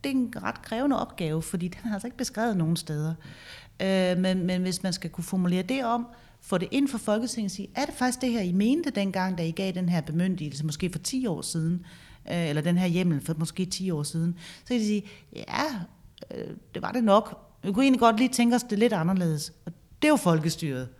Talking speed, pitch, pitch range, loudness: 245 wpm, 185 Hz, 165-230 Hz, -27 LUFS